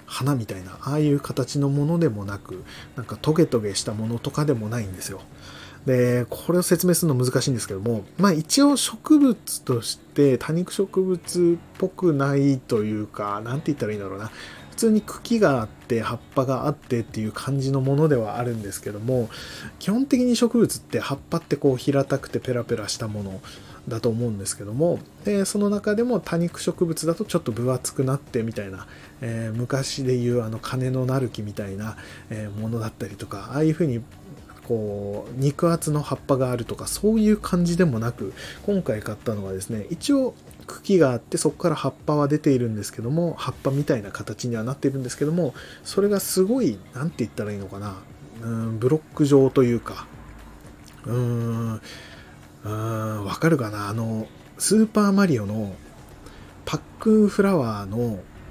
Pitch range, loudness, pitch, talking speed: 110-165 Hz, -24 LUFS, 130 Hz, 370 characters per minute